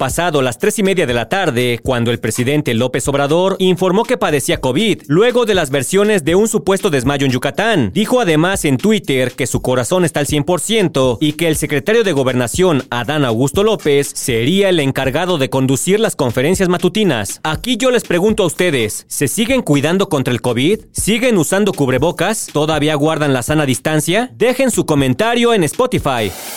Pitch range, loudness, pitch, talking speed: 135-195 Hz, -14 LUFS, 155 Hz, 180 wpm